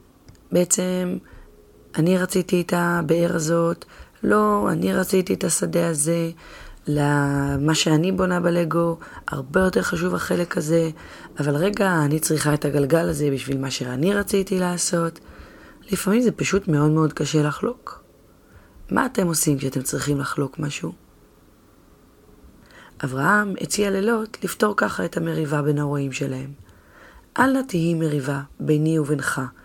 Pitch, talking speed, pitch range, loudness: 165 Hz, 130 wpm, 145-180 Hz, -22 LUFS